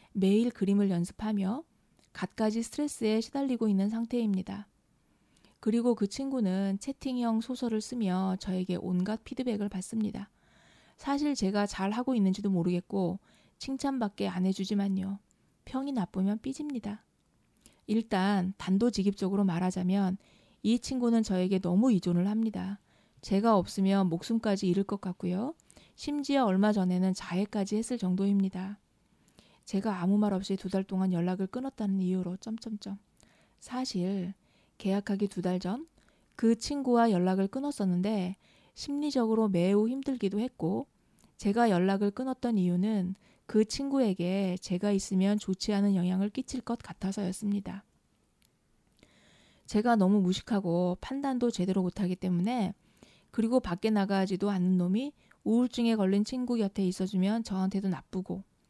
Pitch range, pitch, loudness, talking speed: 190-230 Hz, 200 Hz, -30 LUFS, 310 characters per minute